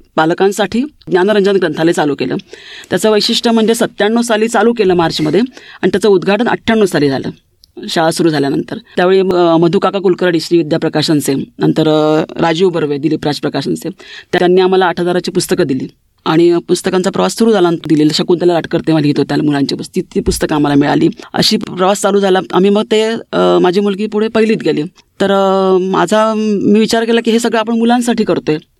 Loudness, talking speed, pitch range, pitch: -12 LUFS, 165 wpm, 165-215 Hz, 185 Hz